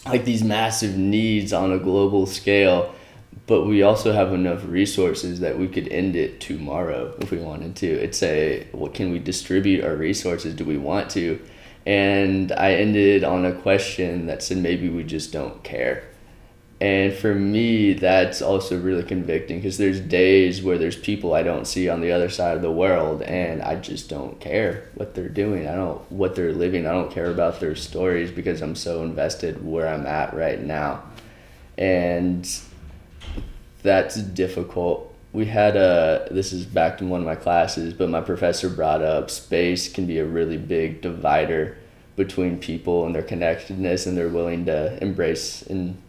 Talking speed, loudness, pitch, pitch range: 180 wpm, -22 LUFS, 90 Hz, 85-95 Hz